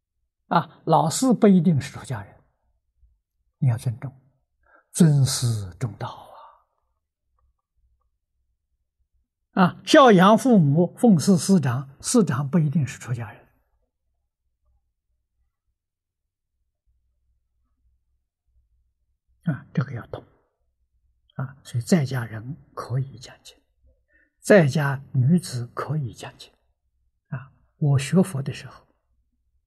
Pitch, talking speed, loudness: 100 Hz, 135 characters per minute, -21 LUFS